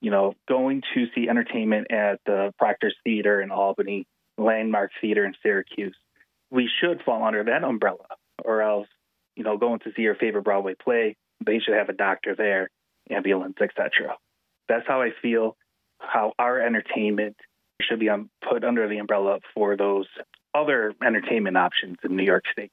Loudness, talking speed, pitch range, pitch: -24 LUFS, 165 wpm, 100-115 Hz, 105 Hz